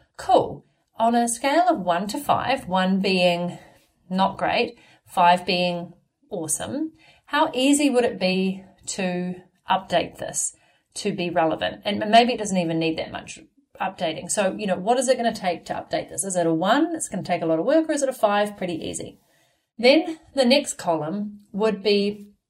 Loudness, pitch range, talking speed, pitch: -23 LUFS, 175-245 Hz, 190 wpm, 195 Hz